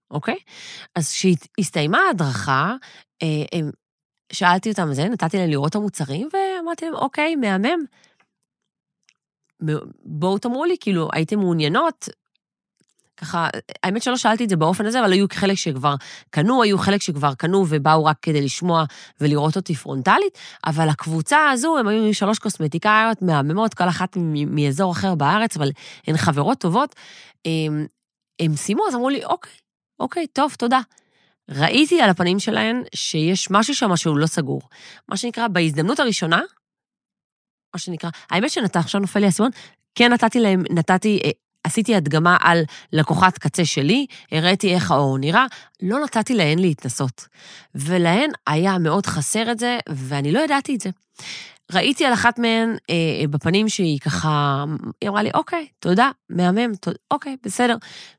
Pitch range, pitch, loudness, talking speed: 155-225 Hz, 185 Hz, -20 LUFS, 145 wpm